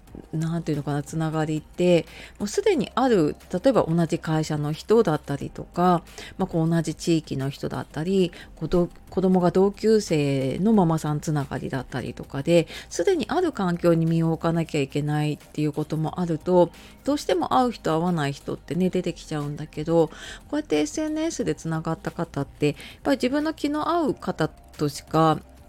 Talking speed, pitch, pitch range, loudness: 365 characters per minute, 165 Hz, 150-185 Hz, -24 LUFS